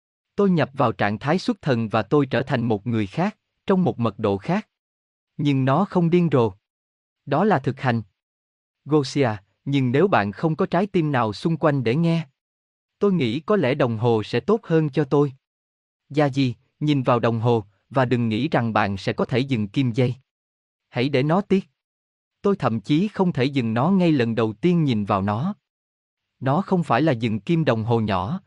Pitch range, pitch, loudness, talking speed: 110-160 Hz, 130 Hz, -22 LUFS, 200 wpm